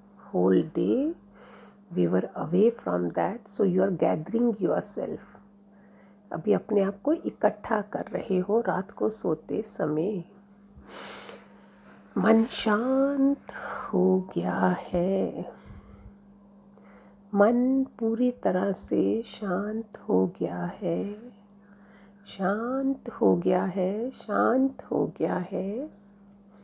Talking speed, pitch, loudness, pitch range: 105 wpm, 200 Hz, -27 LUFS, 185-225 Hz